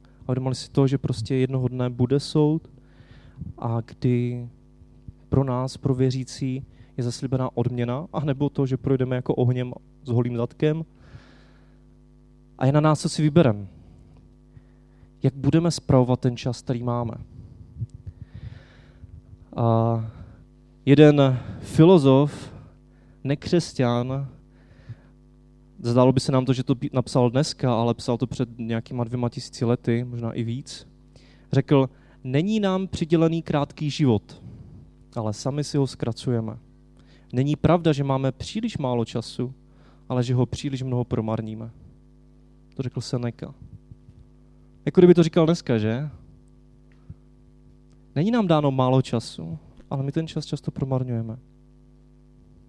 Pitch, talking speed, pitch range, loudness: 130 Hz, 125 wpm, 120-140 Hz, -23 LUFS